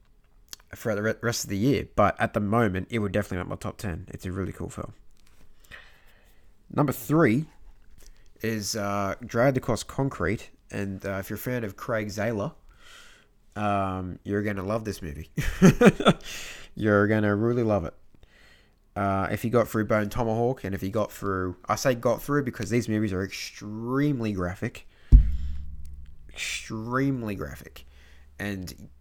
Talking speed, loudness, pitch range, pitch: 155 wpm, -27 LUFS, 95-115 Hz, 105 Hz